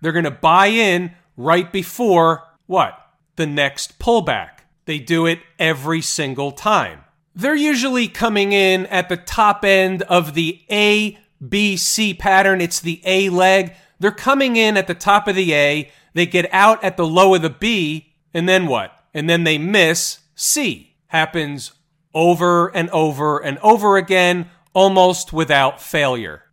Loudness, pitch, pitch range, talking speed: -16 LUFS, 175 Hz, 160-195 Hz, 160 wpm